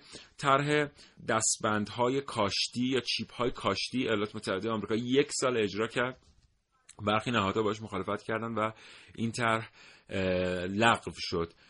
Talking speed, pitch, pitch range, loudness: 125 wpm, 110 Hz, 105-120 Hz, -30 LUFS